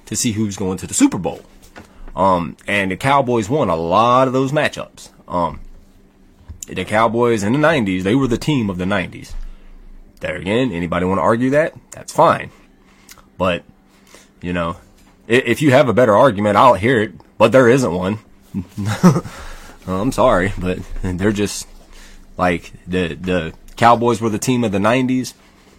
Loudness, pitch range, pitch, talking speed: -16 LUFS, 90-120 Hz, 100 Hz, 170 wpm